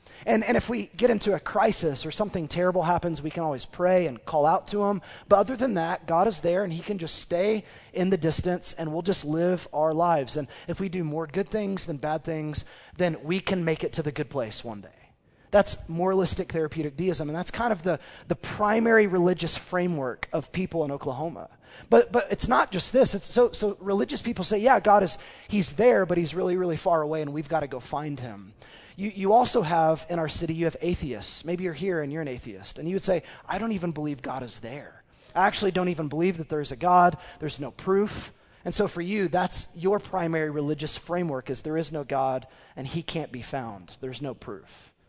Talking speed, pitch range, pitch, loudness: 230 wpm, 150-190 Hz, 170 Hz, -26 LUFS